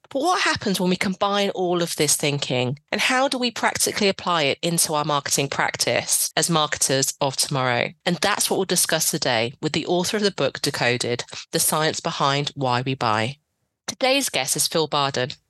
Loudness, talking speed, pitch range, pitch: -21 LUFS, 190 wpm, 140-185 Hz, 155 Hz